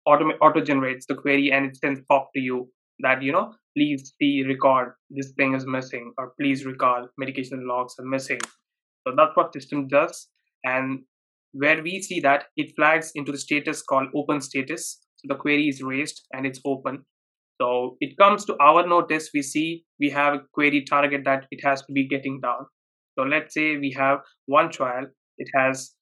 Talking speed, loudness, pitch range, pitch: 190 wpm, -23 LUFS, 135-150 Hz, 140 Hz